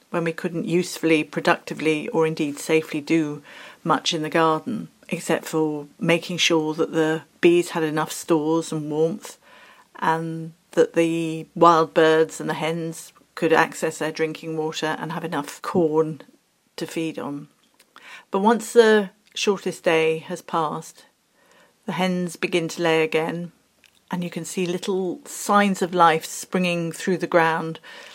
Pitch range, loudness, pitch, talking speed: 160-175 Hz, -22 LUFS, 165 Hz, 150 wpm